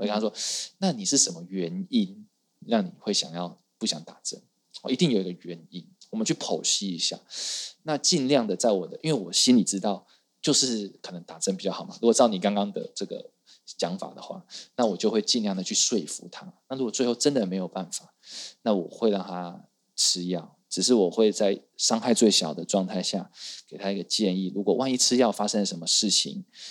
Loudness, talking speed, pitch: -25 LUFS, 300 characters per minute, 105 Hz